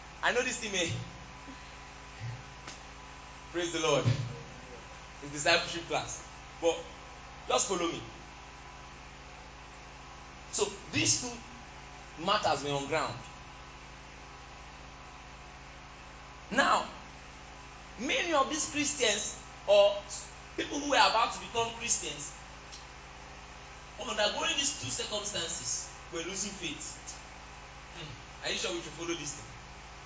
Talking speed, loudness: 95 wpm, -31 LUFS